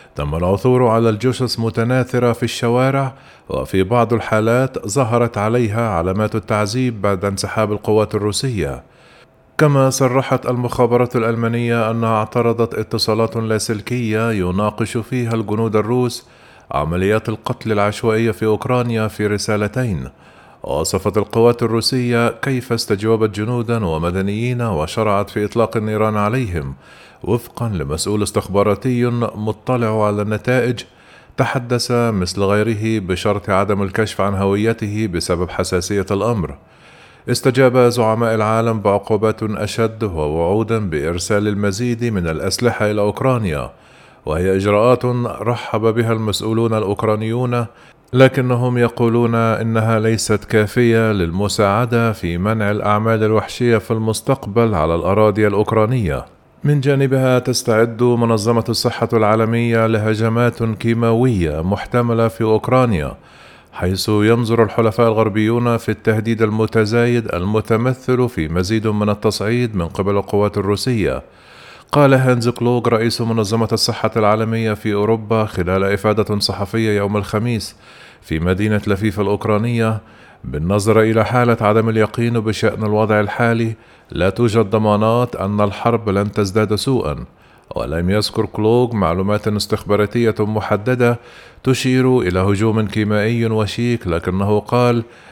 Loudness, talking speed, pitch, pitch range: -17 LUFS, 110 wpm, 110 Hz, 105-120 Hz